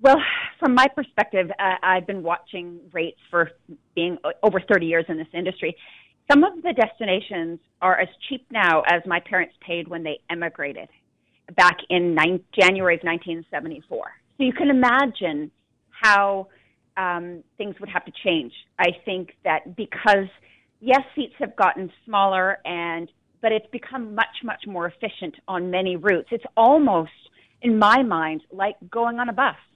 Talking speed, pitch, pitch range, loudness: 160 wpm, 185 Hz, 170-225 Hz, -22 LUFS